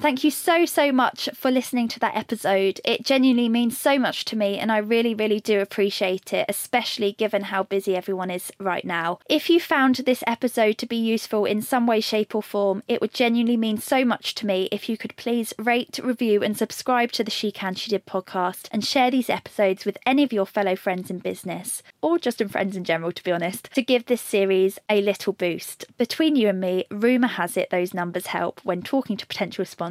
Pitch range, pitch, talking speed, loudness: 195-245 Hz, 215 Hz, 225 wpm, -23 LUFS